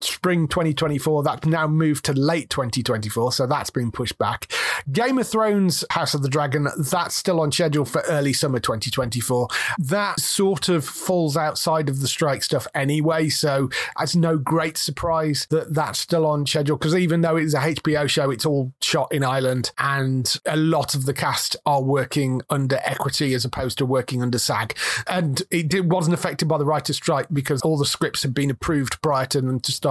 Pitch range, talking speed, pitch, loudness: 135-160 Hz, 195 wpm, 150 Hz, -21 LUFS